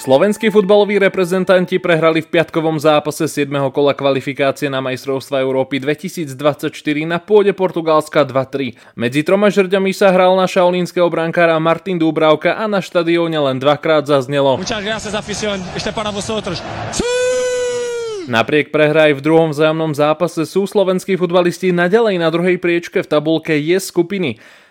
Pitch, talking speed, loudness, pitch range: 170 Hz, 125 wpm, -15 LUFS, 150-190 Hz